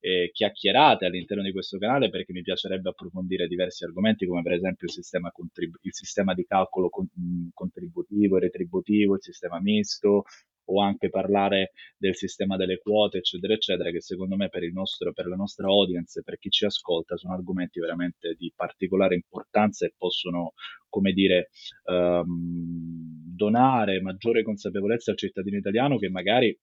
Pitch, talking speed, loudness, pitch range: 95 Hz, 160 wpm, -26 LUFS, 90-100 Hz